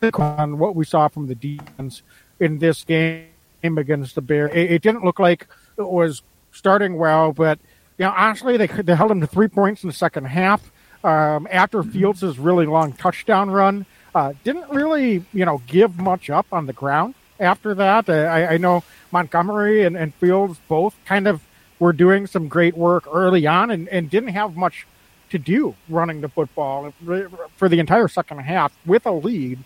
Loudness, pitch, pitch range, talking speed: -19 LUFS, 175 Hz, 155-195 Hz, 190 wpm